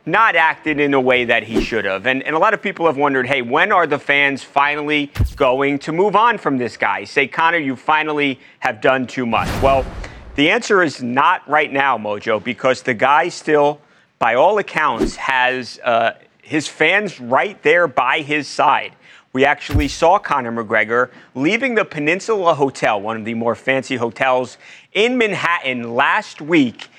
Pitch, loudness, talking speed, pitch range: 140 Hz, -17 LUFS, 180 wpm, 125-155 Hz